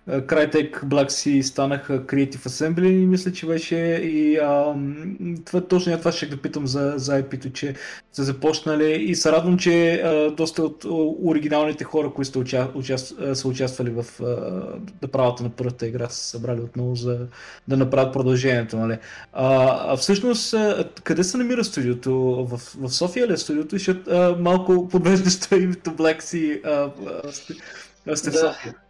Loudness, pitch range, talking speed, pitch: -22 LUFS, 130-170 Hz, 155 wpm, 145 Hz